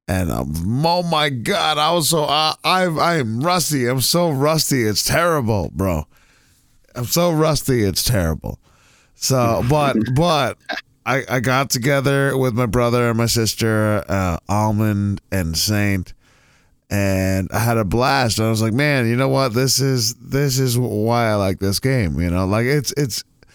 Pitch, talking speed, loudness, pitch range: 120 Hz, 170 wpm, -18 LUFS, 105-140 Hz